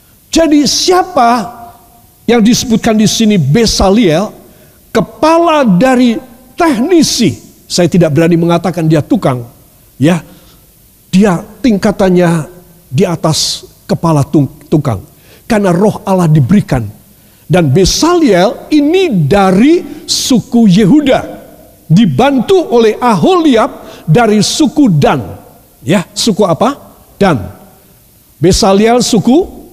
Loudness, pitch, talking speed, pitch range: -9 LUFS, 210 Hz, 90 wpm, 170-255 Hz